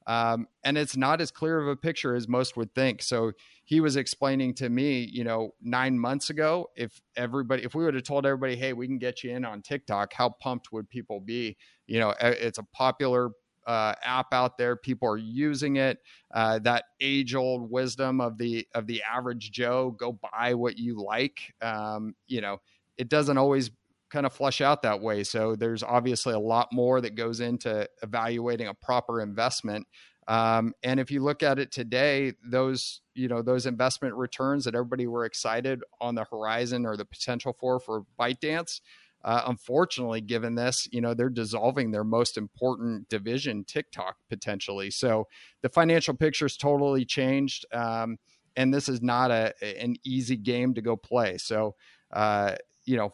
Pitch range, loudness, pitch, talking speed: 115-130 Hz, -28 LUFS, 125 Hz, 185 wpm